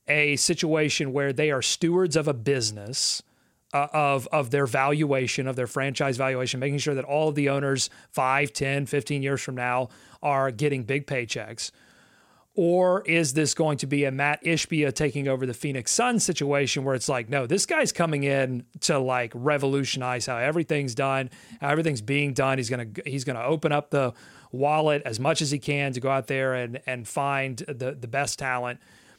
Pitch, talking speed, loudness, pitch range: 140 Hz, 195 wpm, -25 LUFS, 130-150 Hz